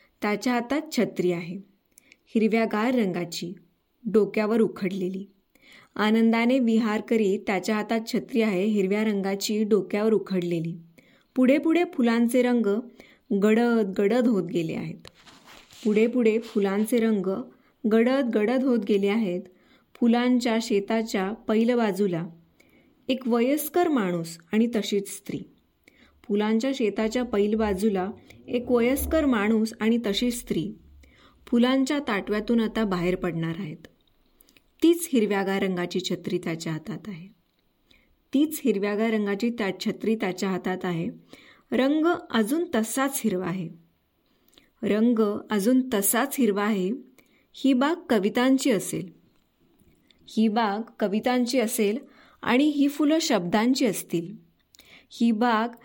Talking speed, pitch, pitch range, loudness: 110 wpm, 220 Hz, 195-245 Hz, -25 LUFS